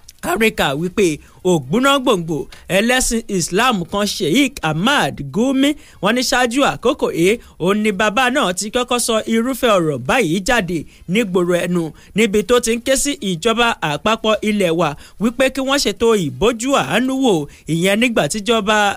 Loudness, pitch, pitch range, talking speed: -17 LUFS, 215 Hz, 180-250 Hz, 170 wpm